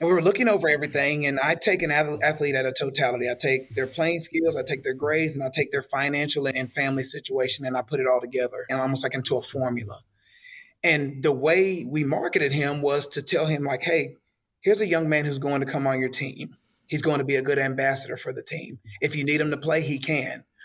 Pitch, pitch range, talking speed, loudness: 145 Hz, 135-155 Hz, 245 wpm, -24 LUFS